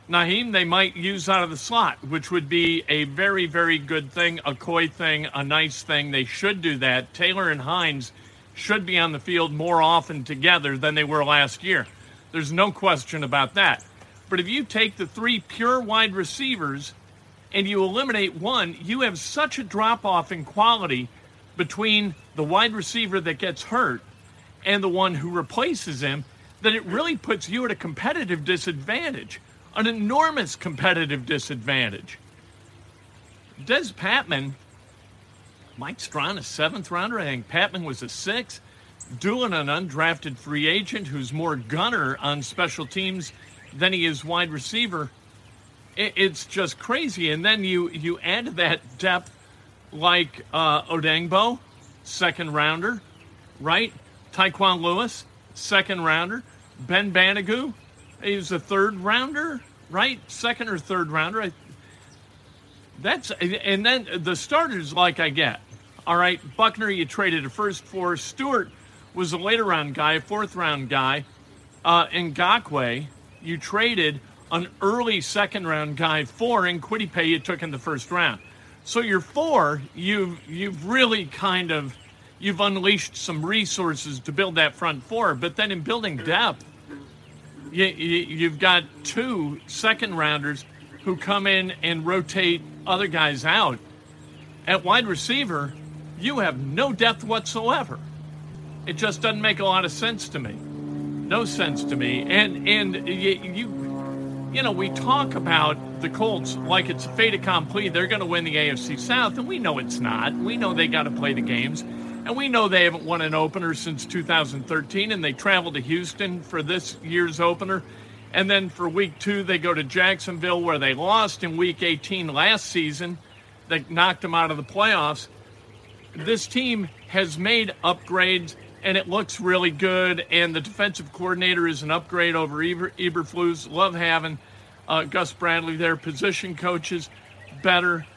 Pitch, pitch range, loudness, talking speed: 170 Hz, 145-195 Hz, -23 LUFS, 155 wpm